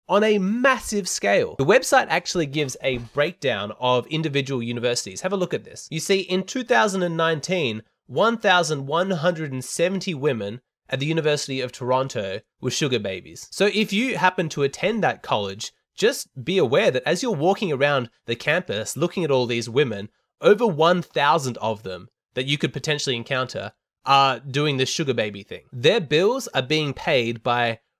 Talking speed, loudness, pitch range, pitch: 165 wpm, -22 LUFS, 125-180 Hz, 145 Hz